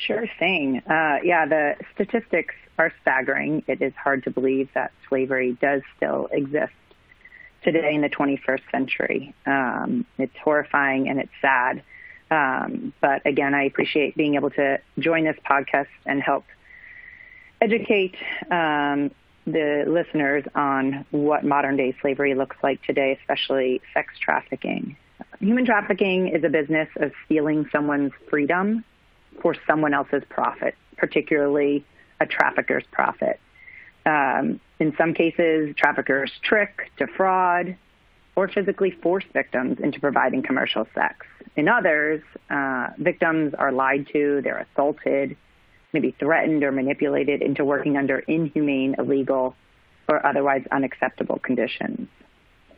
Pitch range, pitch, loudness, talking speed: 140-170 Hz, 145 Hz, -23 LUFS, 125 wpm